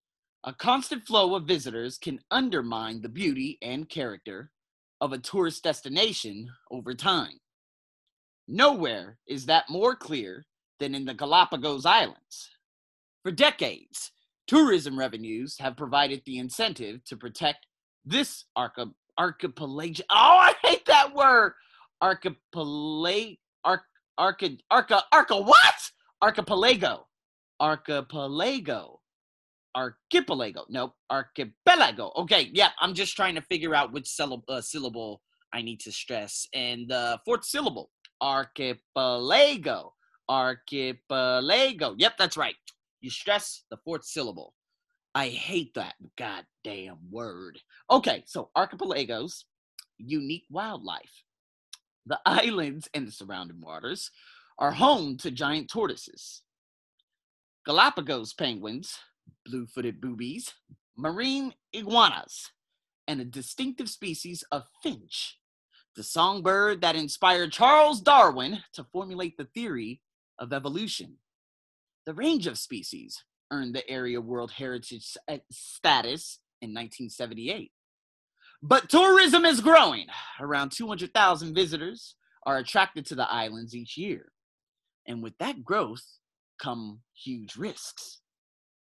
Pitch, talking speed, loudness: 150 Hz, 115 wpm, -25 LUFS